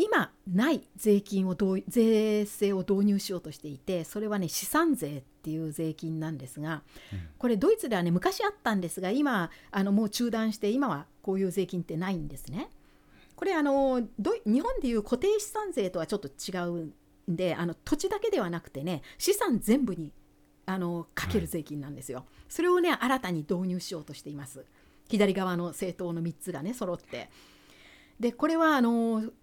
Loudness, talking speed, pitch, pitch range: -30 LUFS, 345 characters per minute, 195 Hz, 165-235 Hz